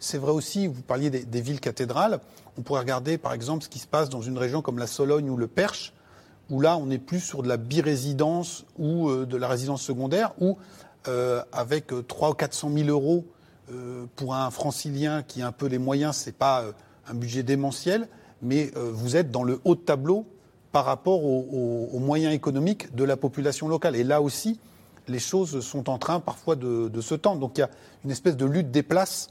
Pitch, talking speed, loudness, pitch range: 140 Hz, 230 wpm, -26 LUFS, 125-160 Hz